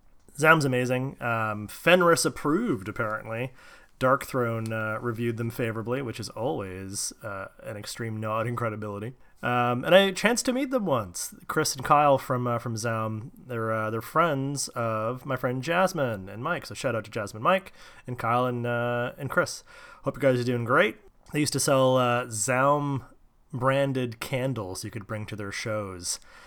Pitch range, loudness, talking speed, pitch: 110-140 Hz, -27 LUFS, 175 wpm, 120 Hz